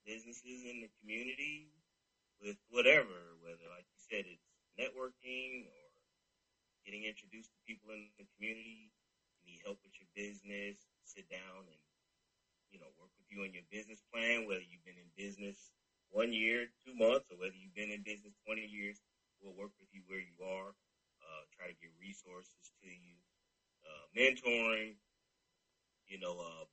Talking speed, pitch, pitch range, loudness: 165 wpm, 105 Hz, 95-115 Hz, -39 LUFS